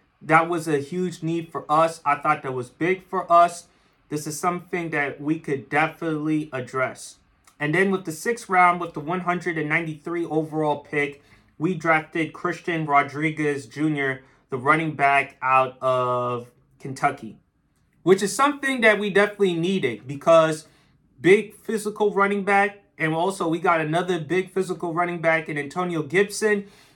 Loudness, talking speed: -23 LUFS, 150 wpm